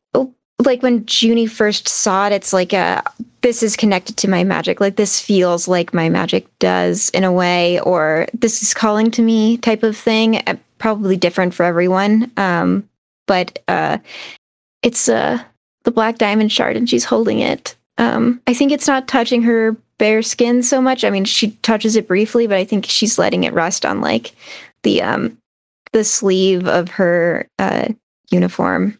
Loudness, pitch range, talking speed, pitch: -15 LUFS, 185-230 Hz, 180 wpm, 215 Hz